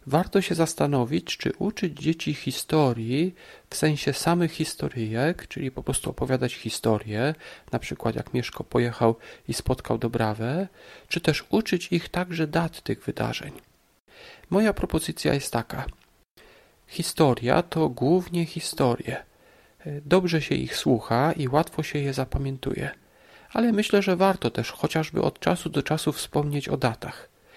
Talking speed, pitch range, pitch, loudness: 135 wpm, 130-175 Hz, 155 Hz, -26 LUFS